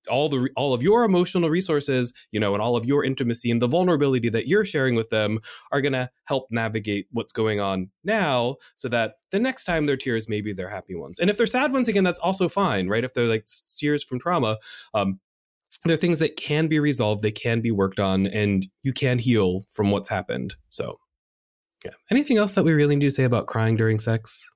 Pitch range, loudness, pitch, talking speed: 110-160 Hz, -23 LUFS, 125 Hz, 220 wpm